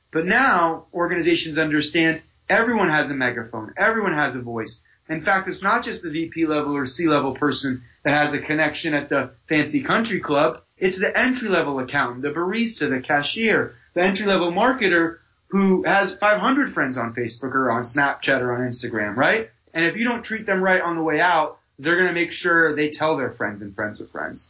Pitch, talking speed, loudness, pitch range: 160 Hz, 200 wpm, -21 LUFS, 140-190 Hz